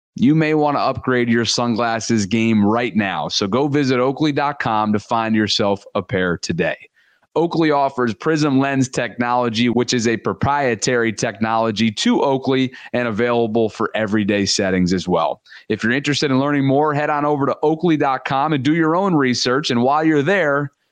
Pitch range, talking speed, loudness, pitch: 115-145 Hz, 170 wpm, -18 LUFS, 125 Hz